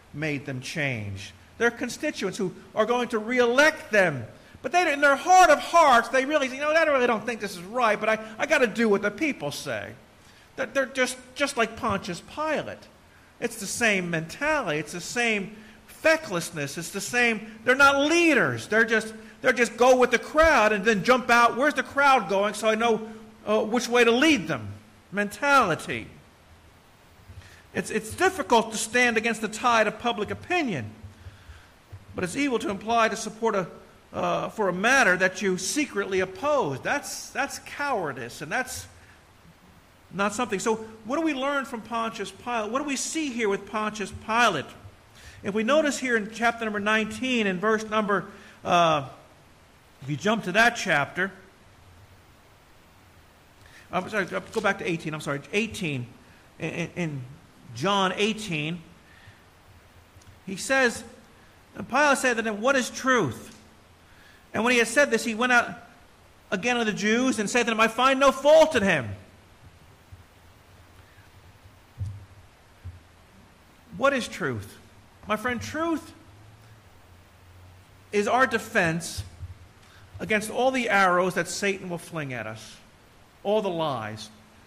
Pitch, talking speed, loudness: 205 Hz, 155 wpm, -24 LUFS